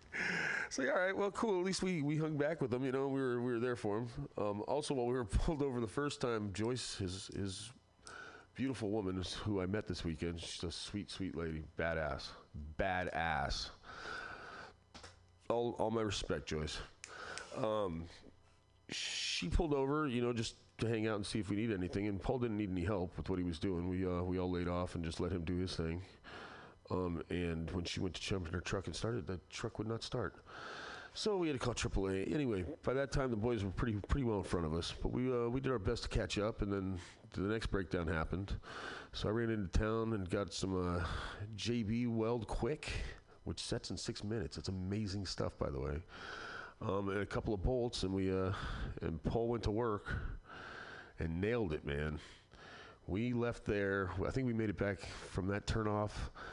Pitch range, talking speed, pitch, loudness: 90-115 Hz, 215 wpm, 100 Hz, -39 LUFS